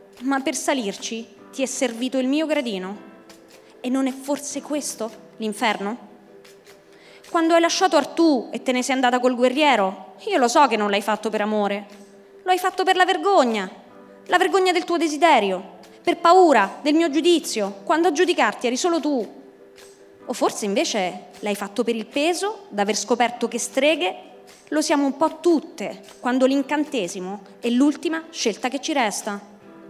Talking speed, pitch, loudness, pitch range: 165 wpm, 260 Hz, -21 LUFS, 210-320 Hz